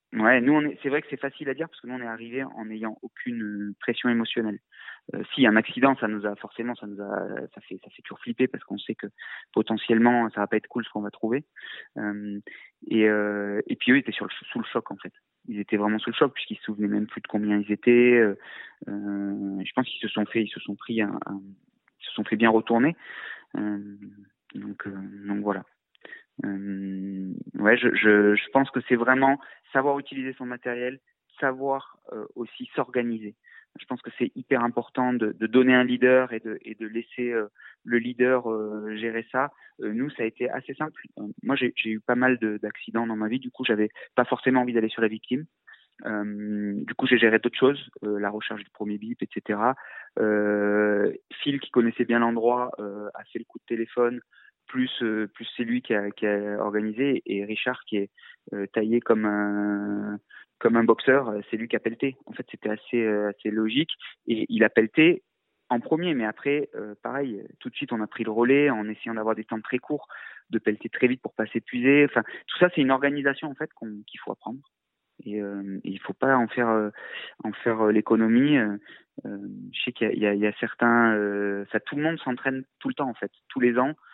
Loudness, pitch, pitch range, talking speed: -25 LUFS, 115 Hz, 105-125 Hz, 225 wpm